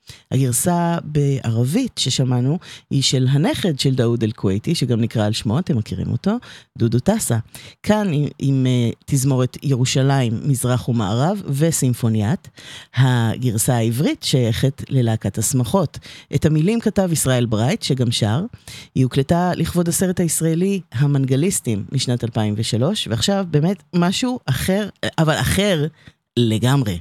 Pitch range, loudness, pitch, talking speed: 120-165 Hz, -19 LUFS, 135 Hz, 120 wpm